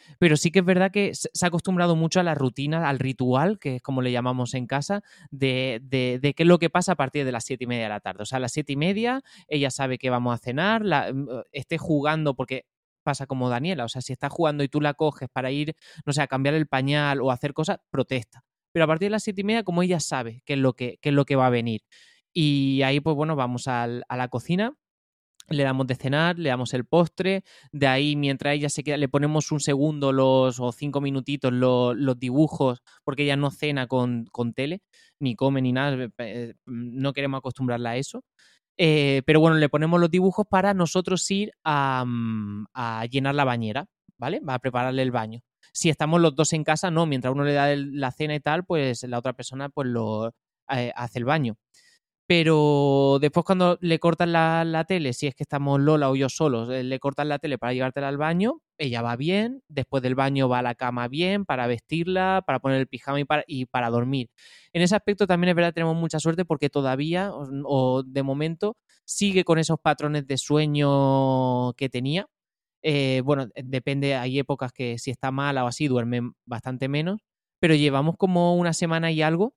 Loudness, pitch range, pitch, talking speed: -24 LUFS, 130-160 Hz, 140 Hz, 220 wpm